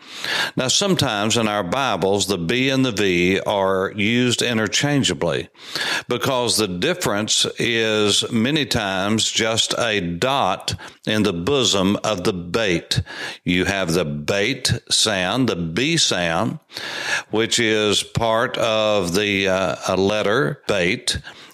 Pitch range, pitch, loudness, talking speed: 95-120 Hz, 105 Hz, -19 LUFS, 125 wpm